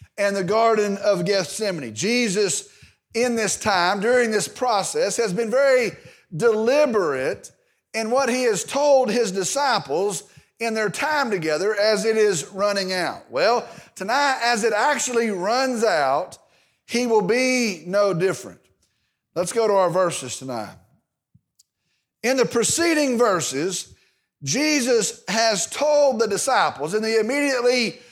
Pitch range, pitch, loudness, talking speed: 200-250 Hz, 225 Hz, -21 LUFS, 130 wpm